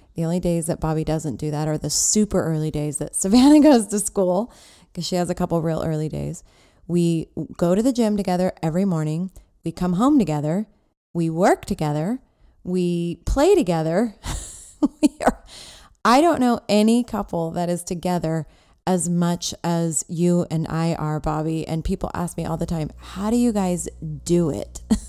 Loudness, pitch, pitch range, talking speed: -21 LUFS, 175 Hz, 160-200 Hz, 180 wpm